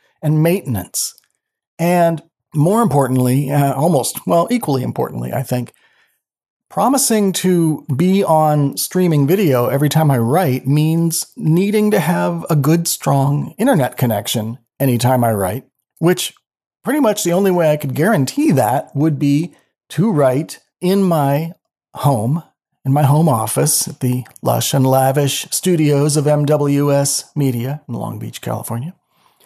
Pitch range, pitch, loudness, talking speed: 135-170 Hz, 150 Hz, -16 LUFS, 140 wpm